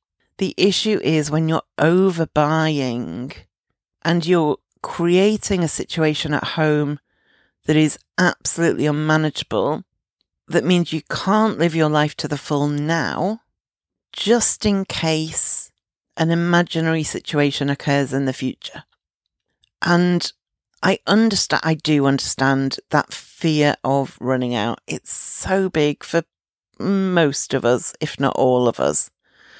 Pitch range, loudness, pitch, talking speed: 145-175 Hz, -19 LUFS, 155 Hz, 125 wpm